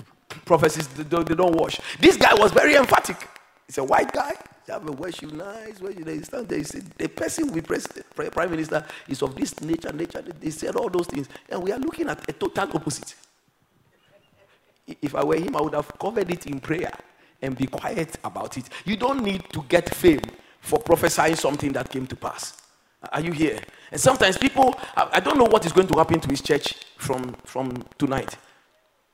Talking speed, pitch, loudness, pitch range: 200 wpm, 165 Hz, -23 LUFS, 145-195 Hz